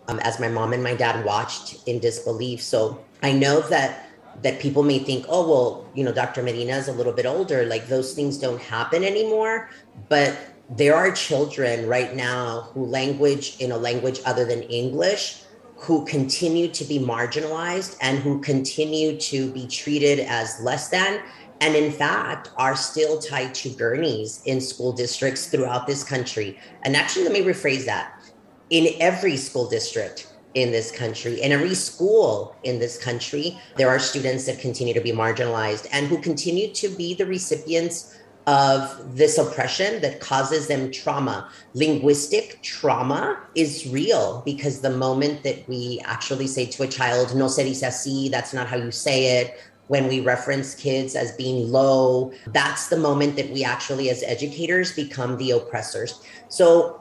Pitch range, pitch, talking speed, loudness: 125-155 Hz, 135 Hz, 170 wpm, -23 LUFS